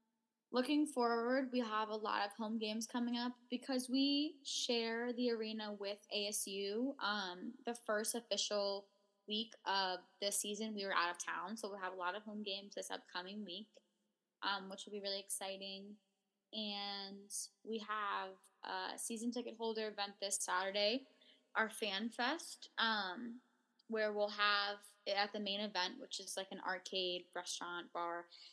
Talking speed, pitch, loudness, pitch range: 160 wpm, 210 Hz, -41 LUFS, 195-230 Hz